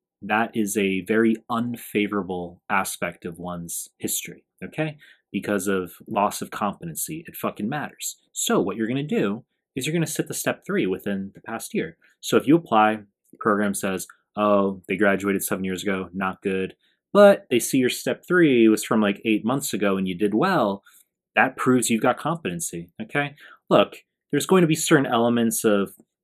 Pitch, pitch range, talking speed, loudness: 110 Hz, 95-135 Hz, 185 wpm, -23 LUFS